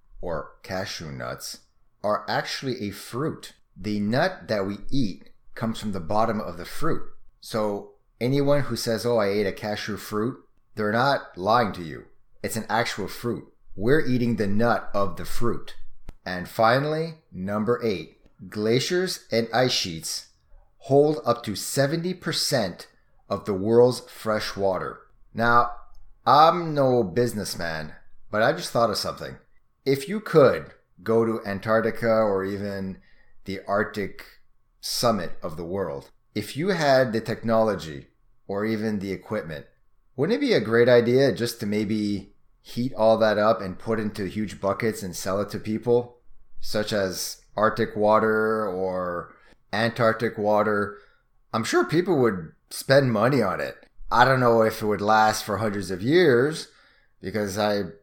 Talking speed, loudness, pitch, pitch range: 150 wpm, -24 LUFS, 110 Hz, 100-120 Hz